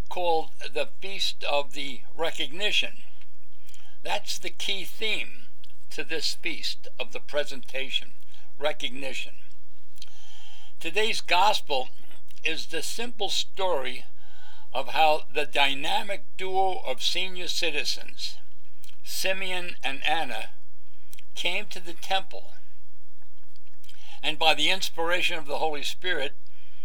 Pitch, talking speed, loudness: 155 Hz, 105 wpm, -28 LUFS